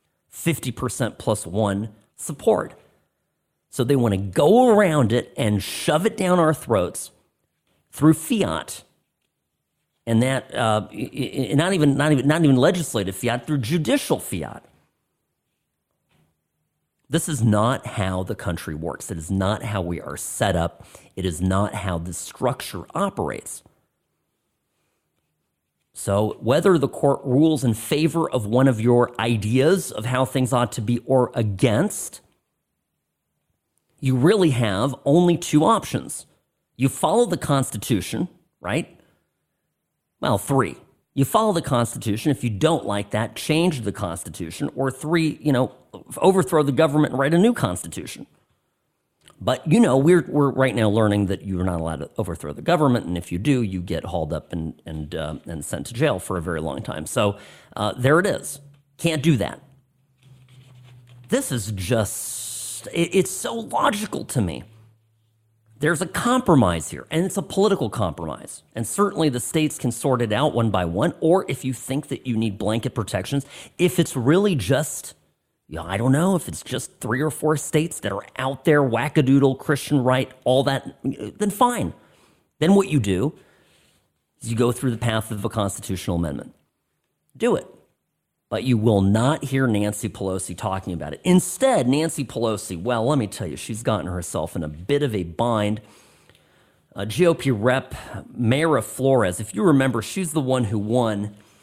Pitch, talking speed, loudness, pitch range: 125 Hz, 160 wpm, -22 LUFS, 105-150 Hz